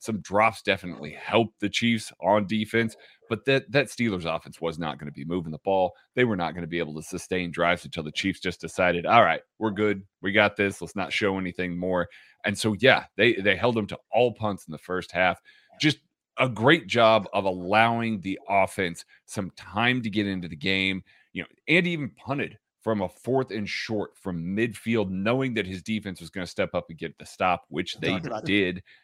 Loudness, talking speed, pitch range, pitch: -26 LUFS, 215 wpm, 90-115 Hz, 100 Hz